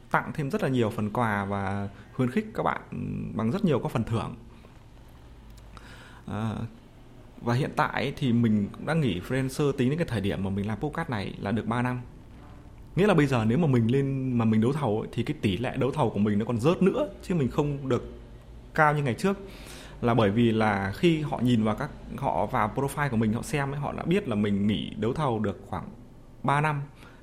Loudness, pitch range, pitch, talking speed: -27 LUFS, 110-140 Hz, 120 Hz, 230 wpm